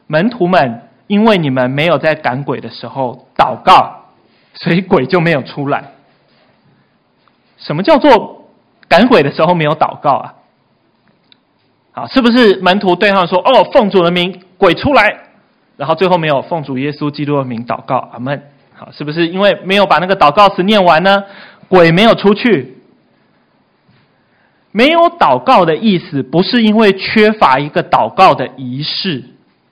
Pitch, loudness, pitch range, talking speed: 180 Hz, -11 LUFS, 145-205 Hz, 235 characters per minute